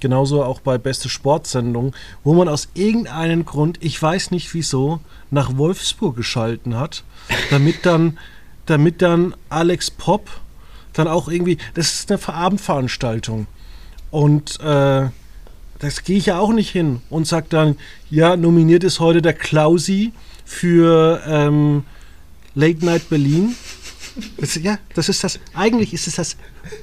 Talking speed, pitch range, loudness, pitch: 145 wpm, 140-175 Hz, -17 LUFS, 160 Hz